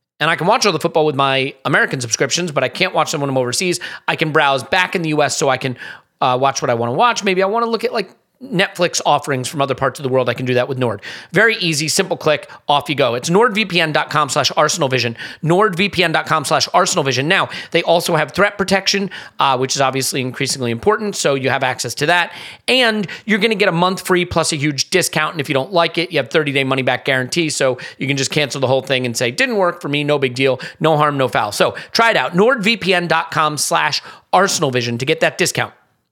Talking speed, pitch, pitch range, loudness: 240 wpm, 155 Hz, 135-180 Hz, -16 LUFS